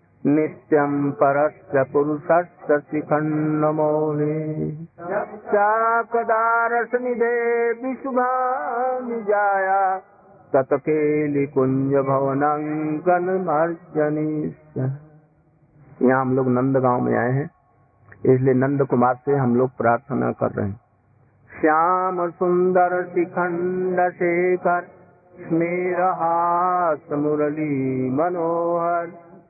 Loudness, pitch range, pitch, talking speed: -21 LUFS, 140-180 Hz, 155 Hz, 75 wpm